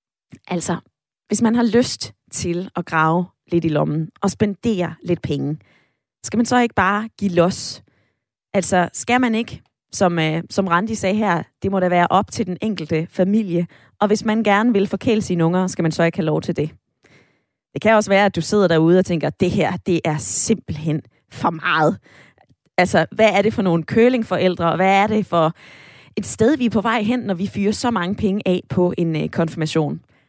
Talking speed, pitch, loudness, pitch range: 205 wpm, 185 Hz, -19 LUFS, 170-215 Hz